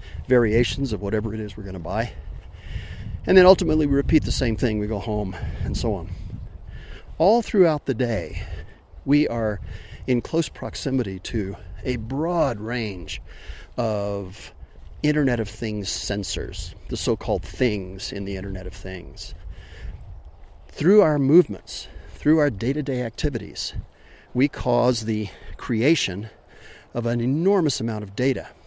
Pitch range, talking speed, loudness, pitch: 95-130 Hz, 145 wpm, -23 LUFS, 110 Hz